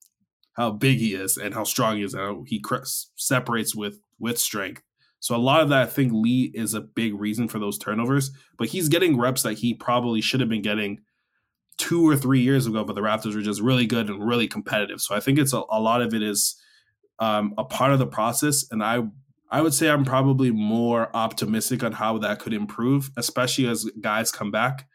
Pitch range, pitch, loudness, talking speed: 110-135 Hz, 120 Hz, -23 LUFS, 225 wpm